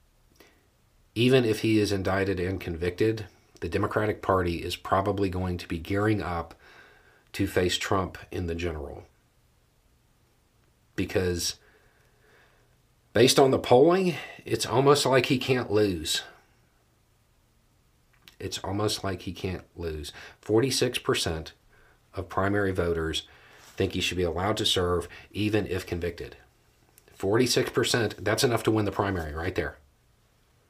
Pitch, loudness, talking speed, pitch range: 95 Hz, -26 LUFS, 125 wpm, 85-105 Hz